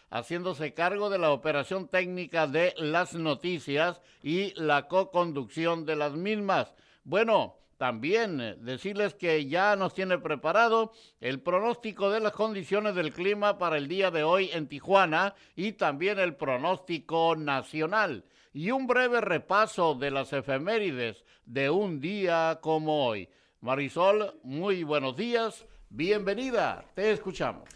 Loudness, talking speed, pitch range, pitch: -29 LUFS, 130 wpm, 155-200 Hz, 175 Hz